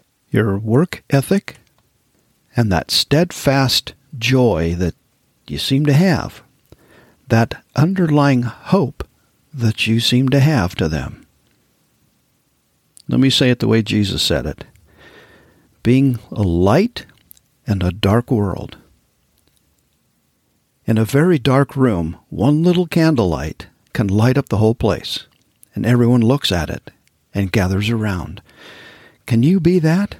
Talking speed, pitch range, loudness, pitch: 125 wpm, 100-140 Hz, -16 LUFS, 120 Hz